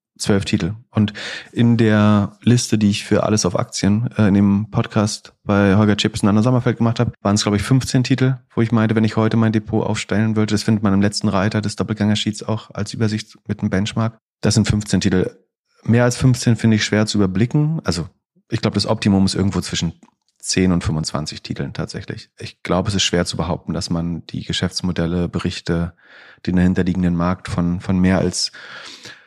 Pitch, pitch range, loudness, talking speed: 105 Hz, 95-110 Hz, -18 LUFS, 200 wpm